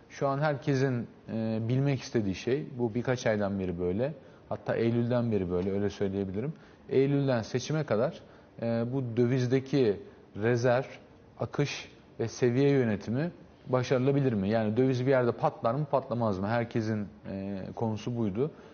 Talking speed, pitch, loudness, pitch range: 140 wpm, 120 Hz, -30 LUFS, 110-135 Hz